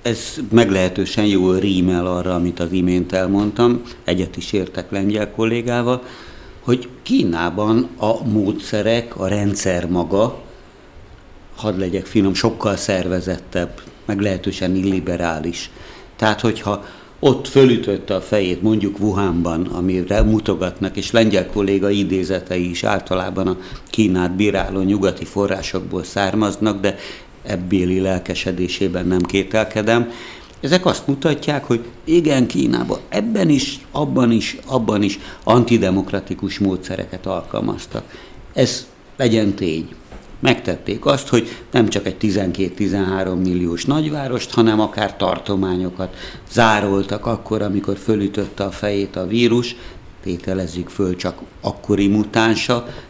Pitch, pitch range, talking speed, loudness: 100 Hz, 95-115 Hz, 110 wpm, -19 LUFS